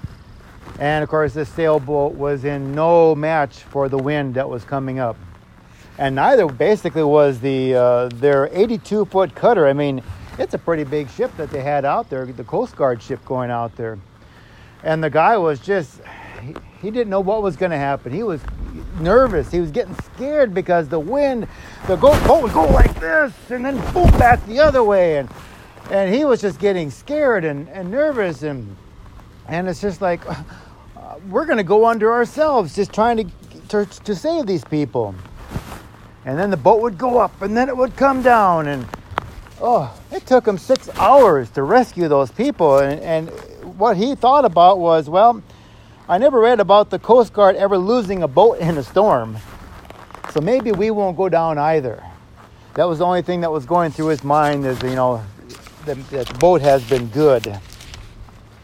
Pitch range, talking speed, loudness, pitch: 130-205 Hz, 185 wpm, -17 LUFS, 155 Hz